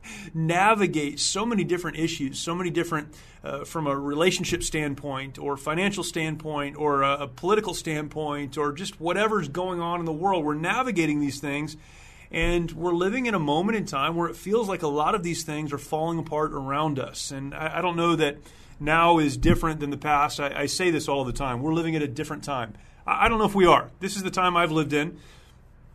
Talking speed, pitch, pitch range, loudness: 215 wpm, 155 Hz, 145-175 Hz, -25 LUFS